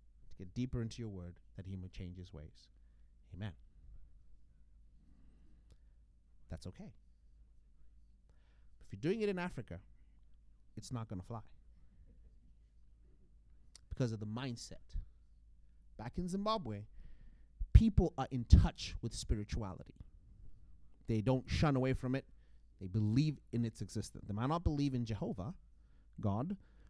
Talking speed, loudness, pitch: 125 wpm, -38 LUFS, 95 Hz